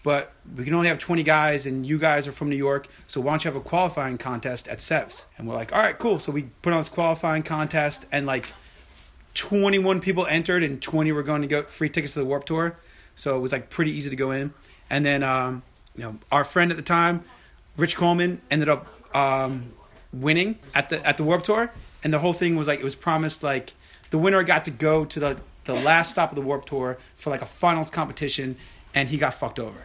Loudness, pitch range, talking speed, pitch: -24 LUFS, 135-165 Hz, 240 wpm, 150 Hz